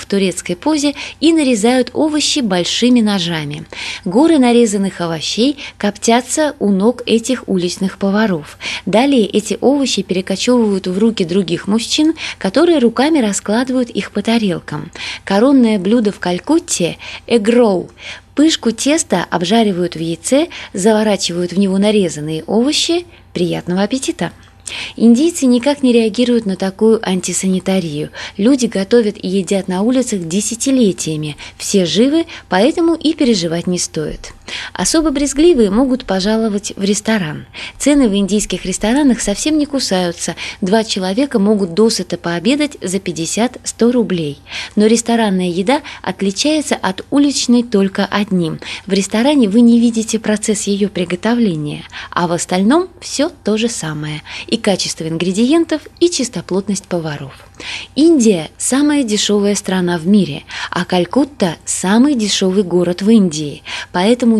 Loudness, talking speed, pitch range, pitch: -15 LUFS, 125 wpm, 185-250 Hz, 215 Hz